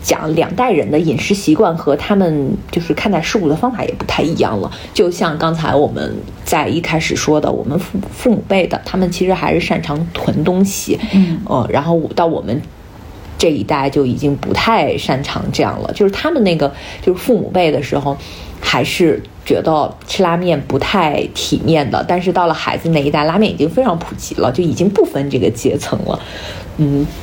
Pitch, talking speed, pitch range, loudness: 170 Hz, 290 characters per minute, 150-195 Hz, -15 LUFS